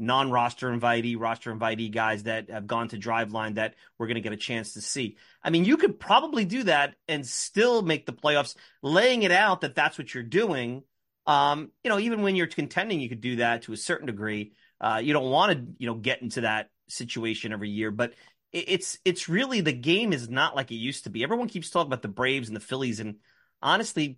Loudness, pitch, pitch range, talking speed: -27 LUFS, 125 Hz, 115-165 Hz, 230 wpm